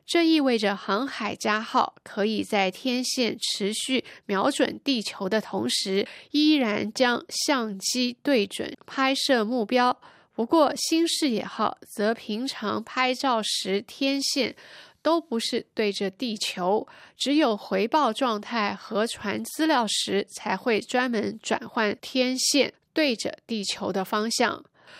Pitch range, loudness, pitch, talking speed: 210-265 Hz, -25 LUFS, 235 Hz, 190 characters per minute